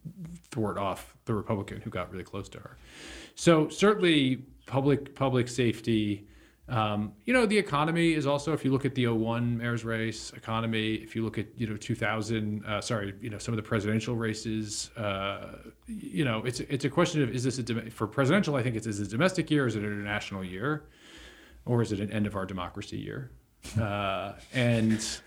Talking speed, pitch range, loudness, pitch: 200 wpm, 105-140 Hz, -29 LUFS, 115 Hz